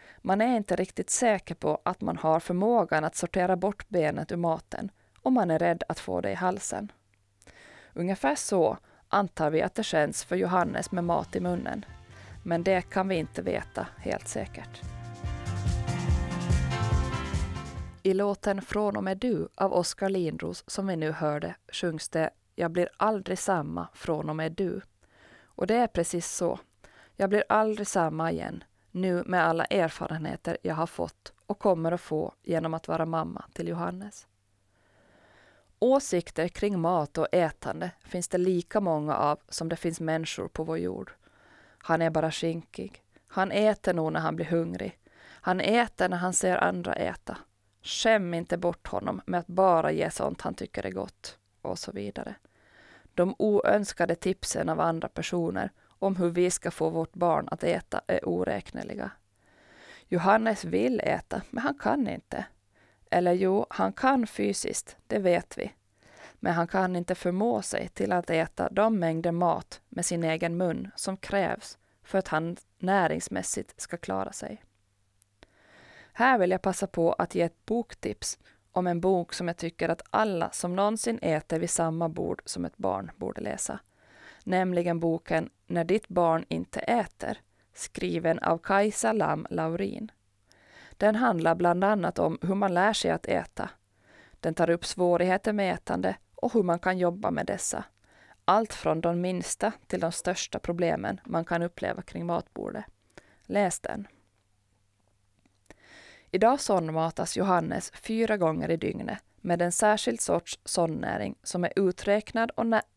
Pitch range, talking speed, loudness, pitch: 155-195 Hz, 160 wpm, -29 LUFS, 175 Hz